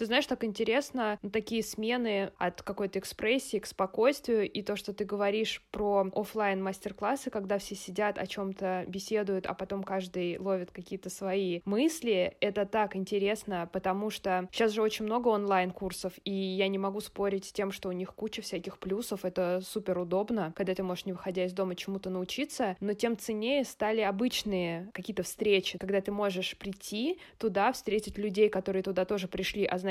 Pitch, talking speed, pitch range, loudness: 200 Hz, 180 wpm, 190-215 Hz, -32 LUFS